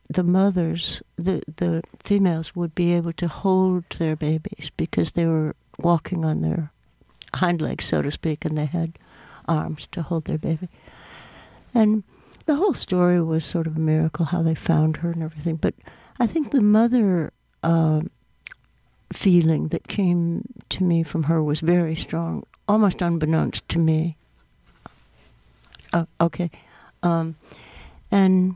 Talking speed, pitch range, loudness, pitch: 145 wpm, 160-180 Hz, -23 LUFS, 170 Hz